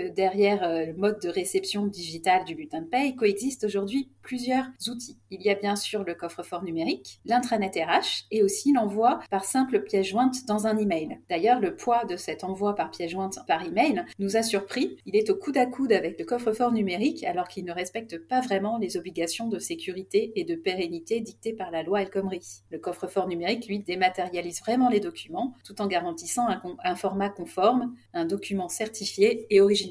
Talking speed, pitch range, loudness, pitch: 195 wpm, 180-240 Hz, -27 LUFS, 200 Hz